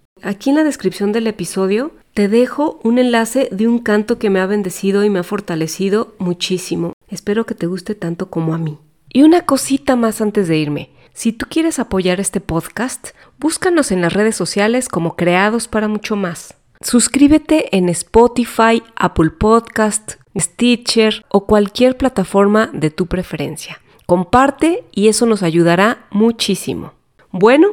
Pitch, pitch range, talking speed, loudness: 210 Hz, 185-235 Hz, 155 wpm, -15 LUFS